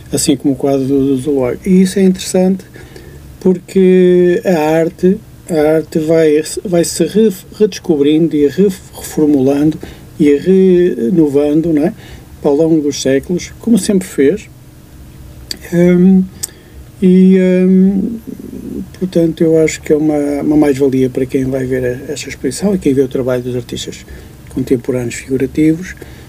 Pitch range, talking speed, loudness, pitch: 140-185 Hz, 130 wpm, -12 LUFS, 155 Hz